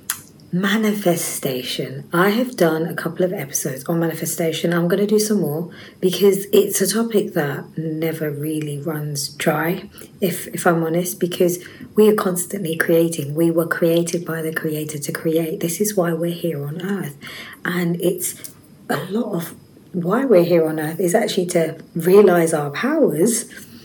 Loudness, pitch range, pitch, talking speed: -20 LUFS, 160-185 Hz, 170 Hz, 165 wpm